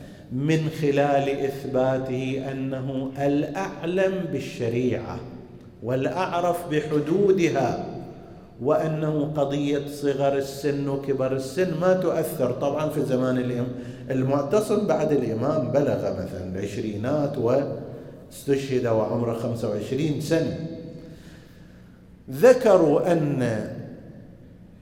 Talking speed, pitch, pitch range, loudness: 75 wpm, 140 Hz, 125-155 Hz, -24 LUFS